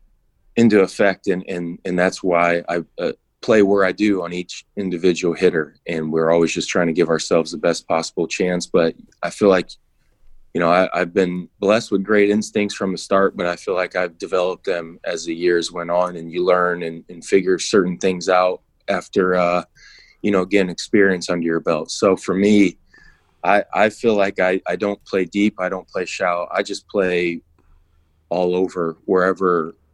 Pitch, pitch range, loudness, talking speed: 90 Hz, 85-95 Hz, -19 LUFS, 195 wpm